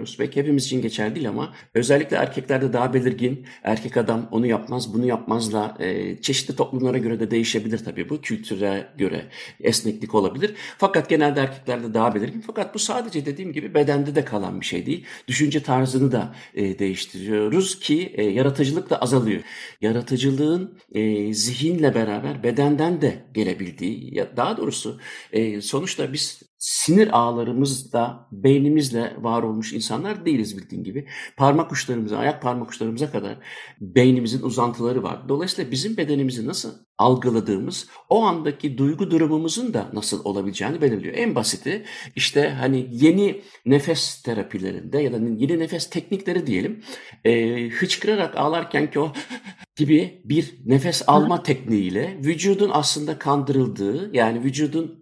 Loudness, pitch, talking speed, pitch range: -22 LUFS, 135 Hz, 135 wpm, 115-155 Hz